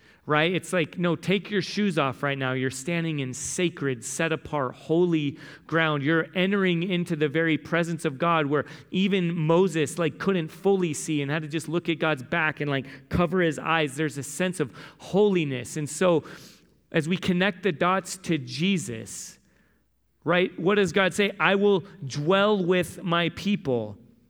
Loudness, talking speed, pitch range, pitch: -25 LUFS, 175 wpm, 145-185 Hz, 165 Hz